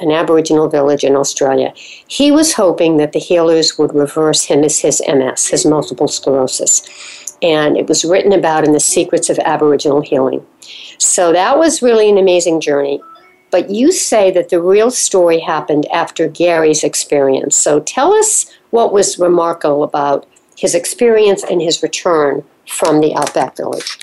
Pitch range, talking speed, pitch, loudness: 150-185 Hz, 160 wpm, 165 Hz, -12 LUFS